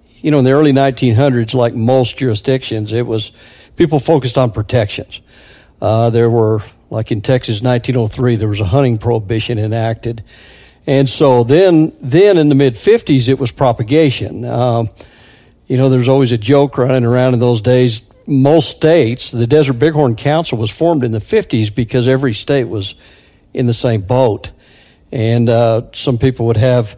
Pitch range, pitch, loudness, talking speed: 115-135 Hz, 125 Hz, -13 LUFS, 170 wpm